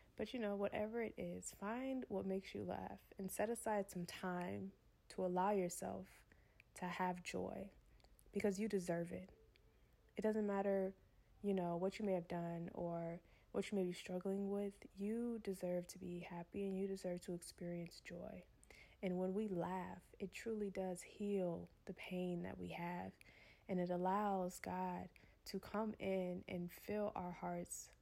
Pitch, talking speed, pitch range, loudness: 185 Hz, 165 wpm, 175-200 Hz, -45 LUFS